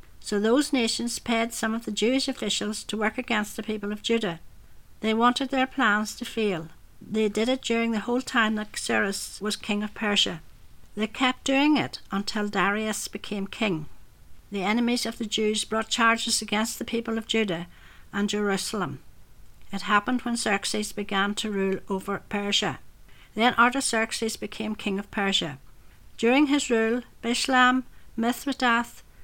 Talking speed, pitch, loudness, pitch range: 160 wpm, 220 Hz, -26 LUFS, 205-235 Hz